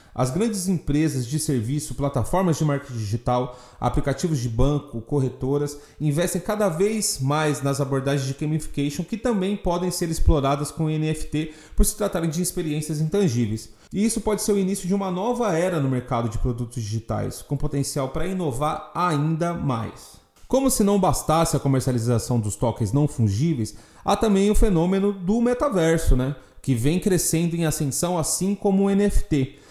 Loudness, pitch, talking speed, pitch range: -23 LUFS, 155 Hz, 165 wpm, 135-185 Hz